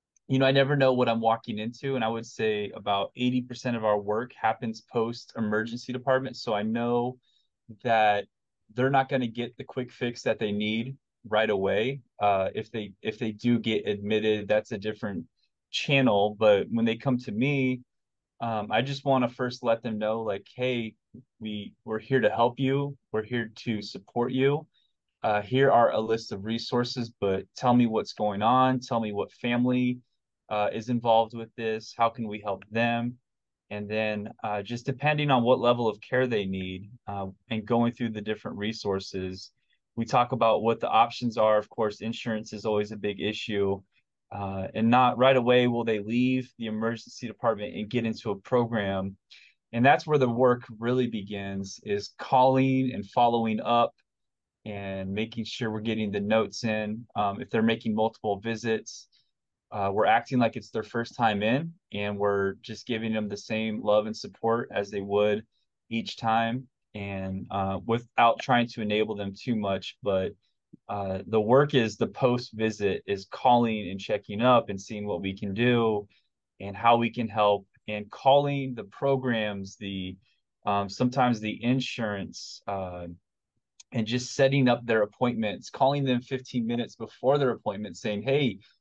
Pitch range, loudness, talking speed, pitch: 105-125 Hz, -27 LUFS, 180 wpm, 115 Hz